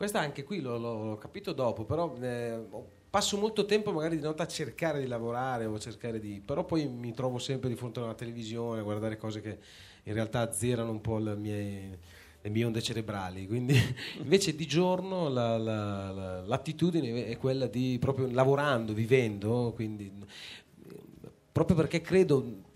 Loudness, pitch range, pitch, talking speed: -32 LUFS, 110-150 Hz, 120 Hz, 175 wpm